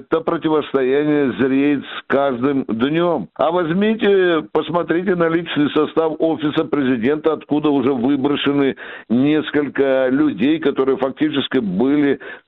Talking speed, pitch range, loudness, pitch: 105 wpm, 135-160 Hz, -18 LUFS, 150 Hz